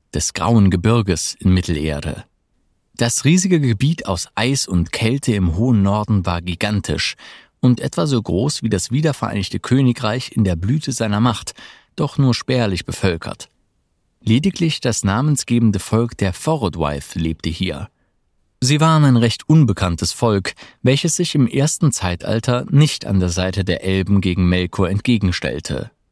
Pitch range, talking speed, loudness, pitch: 95-130 Hz, 140 wpm, -18 LUFS, 110 Hz